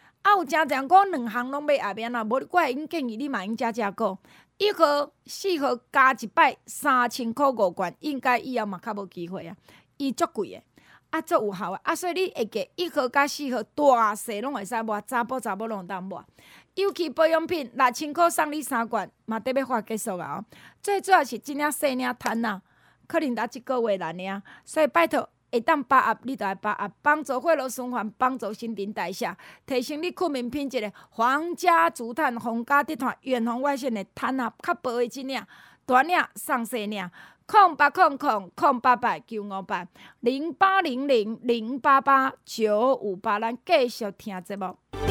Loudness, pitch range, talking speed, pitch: -25 LUFS, 225-295 Hz, 270 characters per minute, 255 Hz